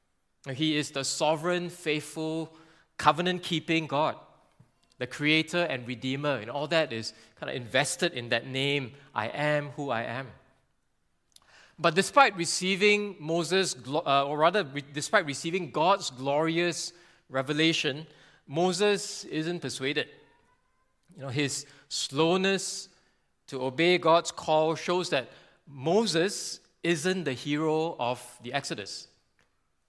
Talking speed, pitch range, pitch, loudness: 115 wpm, 135-175 Hz, 155 Hz, -28 LUFS